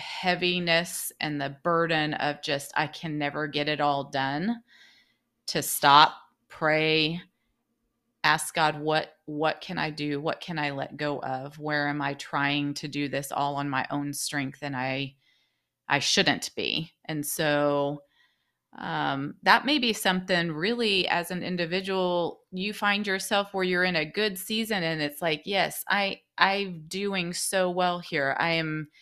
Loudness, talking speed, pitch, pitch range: -27 LUFS, 160 wpm, 155 Hz, 145-185 Hz